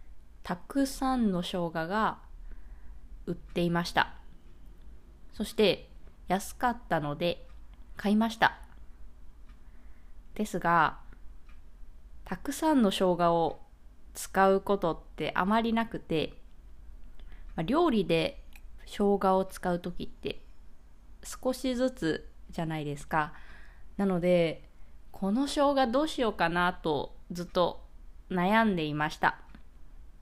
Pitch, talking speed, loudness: 165 Hz, 200 characters per minute, -30 LUFS